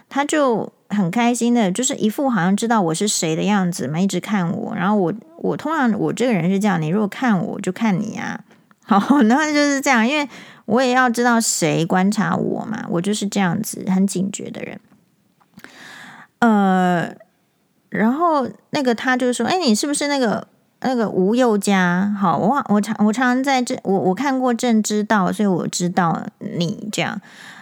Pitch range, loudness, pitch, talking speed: 195-245 Hz, -19 LUFS, 215 Hz, 265 characters per minute